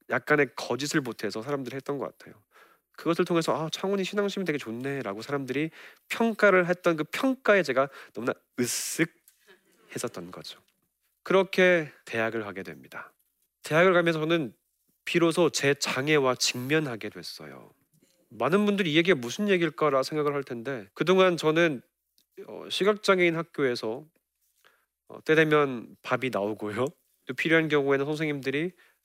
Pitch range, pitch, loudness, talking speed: 130-175 Hz, 150 Hz, -26 LUFS, 315 characters per minute